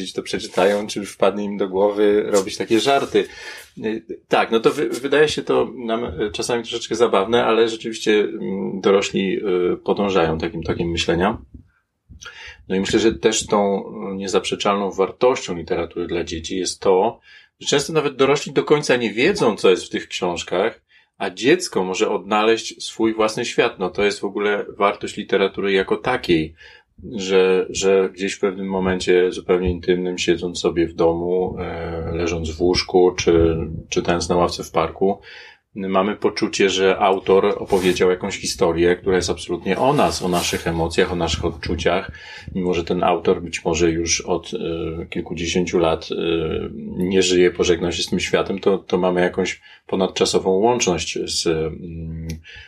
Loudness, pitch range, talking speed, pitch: -20 LUFS, 85-110 Hz, 155 wpm, 95 Hz